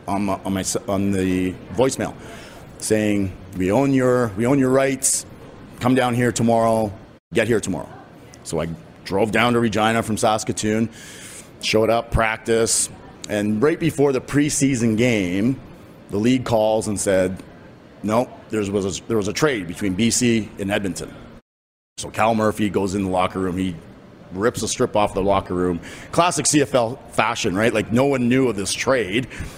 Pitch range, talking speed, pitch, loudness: 95-120 Hz, 170 wpm, 110 Hz, -20 LUFS